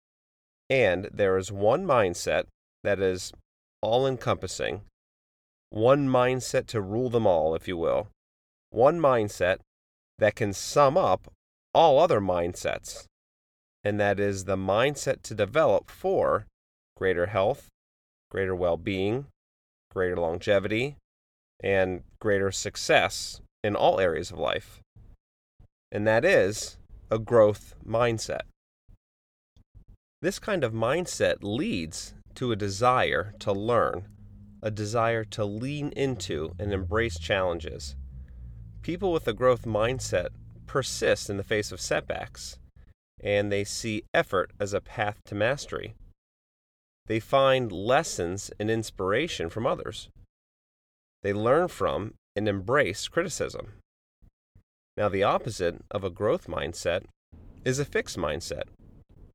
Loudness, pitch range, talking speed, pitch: -27 LUFS, 70-110 Hz, 120 wpm, 100 Hz